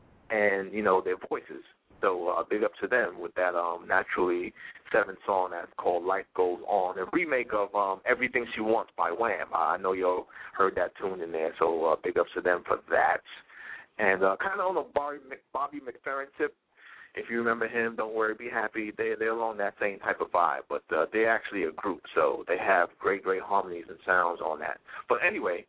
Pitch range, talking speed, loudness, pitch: 95-145 Hz, 215 wpm, -29 LUFS, 110 Hz